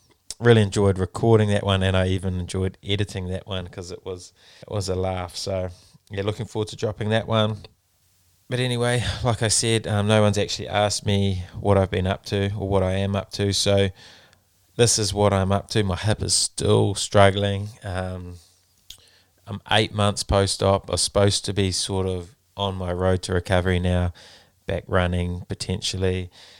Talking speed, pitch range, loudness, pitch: 185 wpm, 95-105 Hz, -22 LUFS, 100 Hz